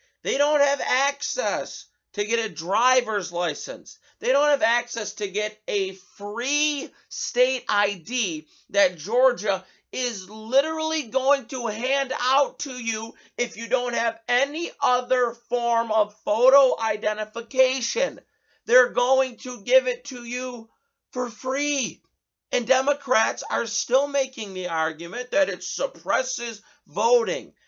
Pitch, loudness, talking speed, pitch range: 250 Hz, -24 LUFS, 130 wpm, 220-275 Hz